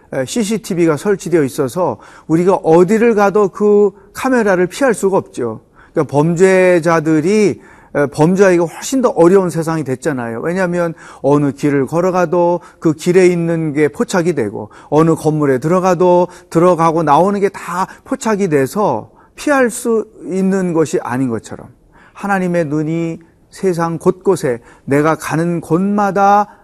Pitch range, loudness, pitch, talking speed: 160-195 Hz, -14 LUFS, 175 Hz, 305 characters per minute